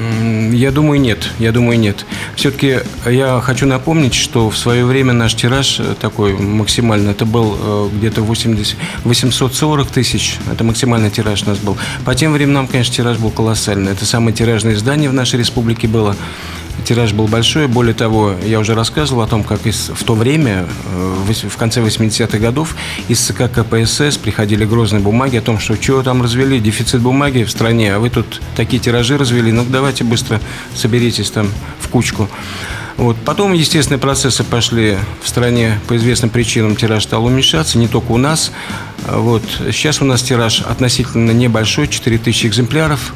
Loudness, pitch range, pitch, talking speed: -13 LUFS, 110-125 Hz, 115 Hz, 165 wpm